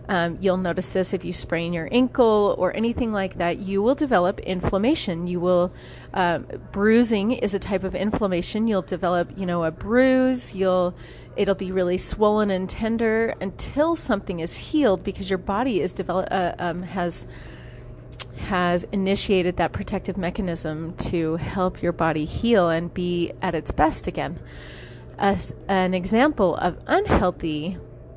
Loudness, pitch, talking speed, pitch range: -23 LUFS, 185 Hz, 155 wpm, 175-205 Hz